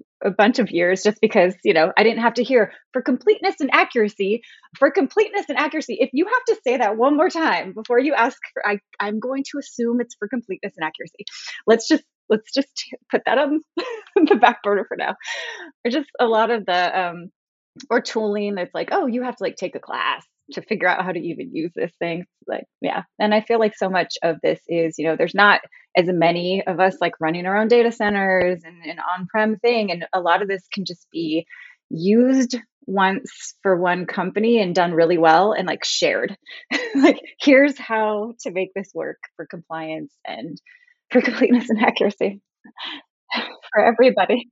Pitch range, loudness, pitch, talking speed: 185-265 Hz, -20 LUFS, 220 Hz, 200 wpm